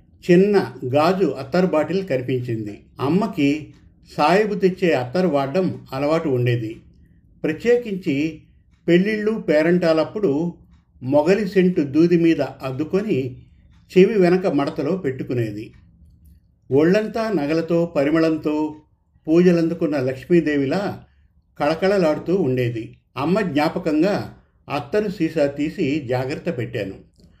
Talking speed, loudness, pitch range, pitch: 85 wpm, -20 LUFS, 130-180 Hz, 155 Hz